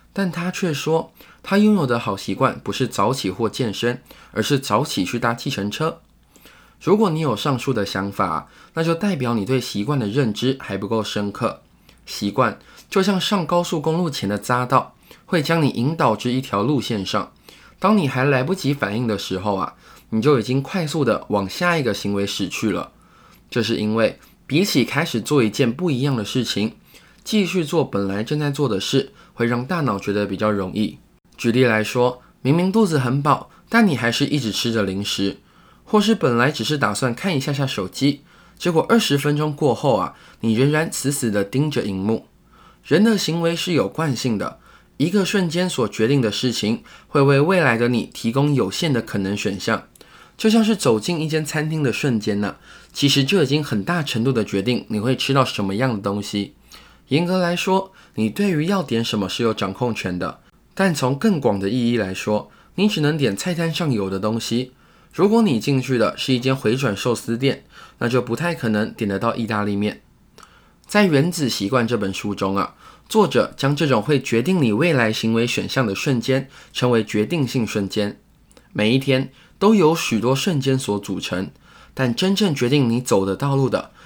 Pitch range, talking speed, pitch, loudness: 110-155 Hz, 275 characters per minute, 130 Hz, -20 LUFS